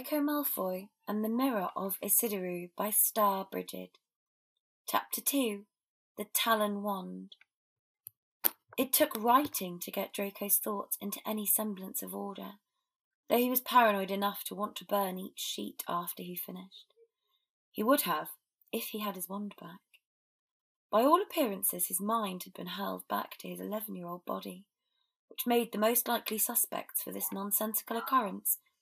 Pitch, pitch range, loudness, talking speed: 210 Hz, 195-255 Hz, -32 LUFS, 155 wpm